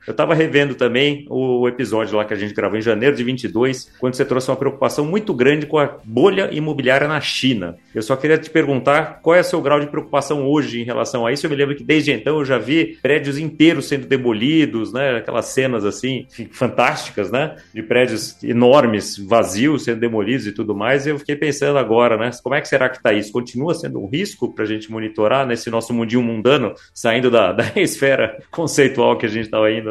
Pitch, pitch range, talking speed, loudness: 130 Hz, 115-145 Hz, 215 wpm, -18 LUFS